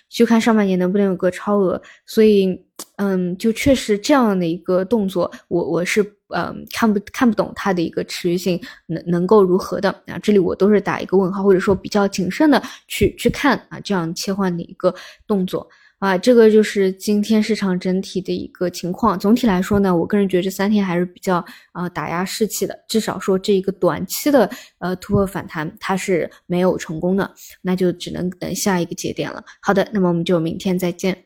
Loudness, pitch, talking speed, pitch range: -19 LUFS, 190 Hz, 310 characters per minute, 180-210 Hz